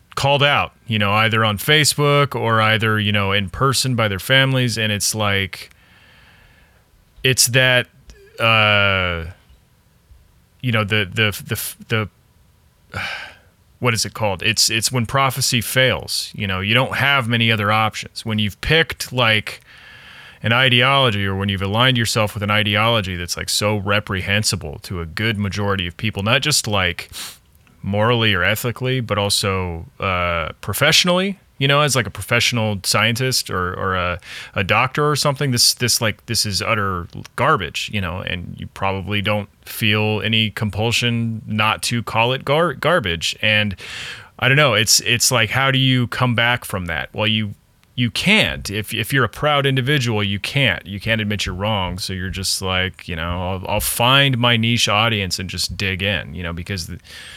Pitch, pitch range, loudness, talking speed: 110 Hz, 100-125 Hz, -17 LUFS, 175 wpm